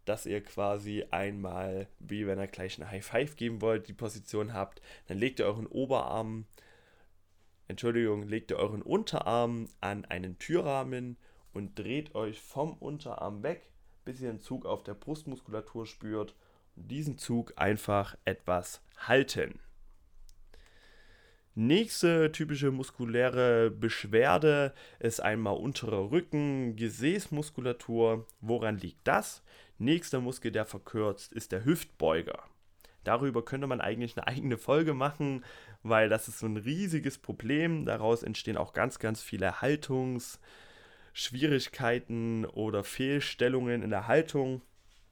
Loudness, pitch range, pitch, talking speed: -32 LUFS, 100-130 Hz, 115 Hz, 125 wpm